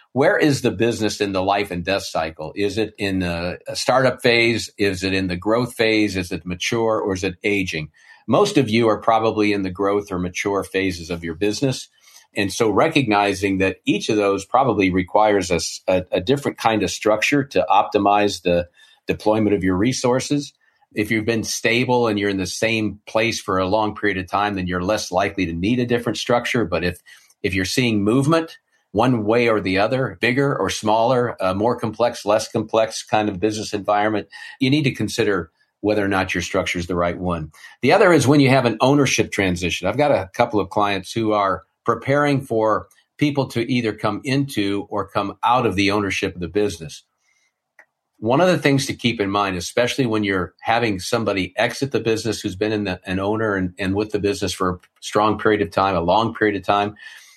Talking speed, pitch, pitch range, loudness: 205 wpm, 105 Hz, 95-115 Hz, -20 LUFS